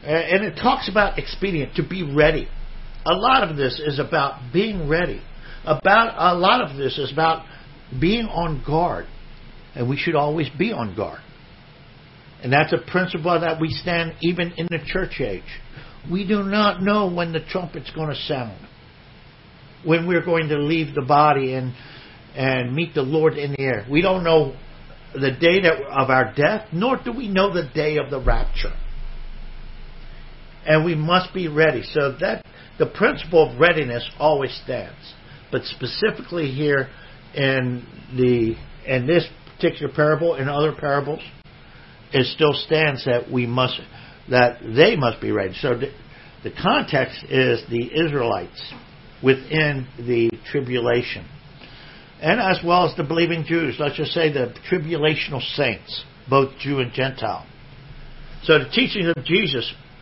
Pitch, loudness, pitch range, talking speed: 155 Hz, -21 LUFS, 135-170 Hz, 155 wpm